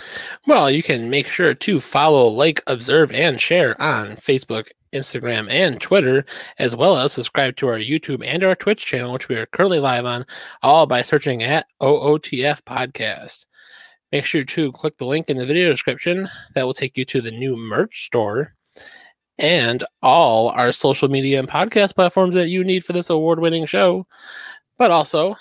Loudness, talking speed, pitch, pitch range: -18 LUFS, 180 wpm, 150 Hz, 130-175 Hz